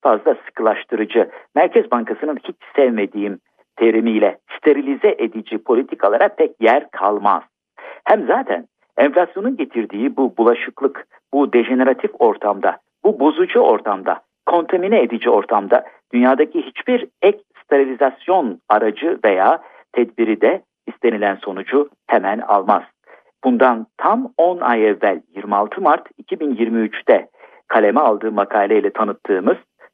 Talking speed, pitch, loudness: 105 wpm, 130 Hz, -17 LUFS